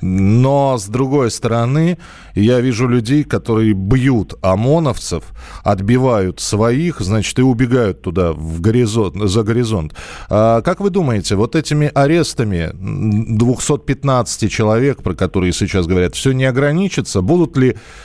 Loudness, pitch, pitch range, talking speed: -15 LUFS, 115 Hz, 100-135 Hz, 125 wpm